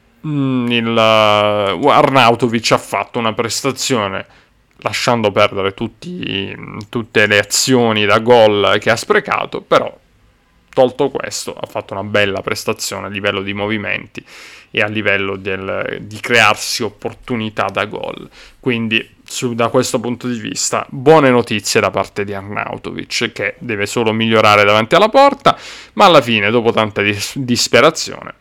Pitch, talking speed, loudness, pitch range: 110 Hz, 135 wpm, -14 LUFS, 100-125 Hz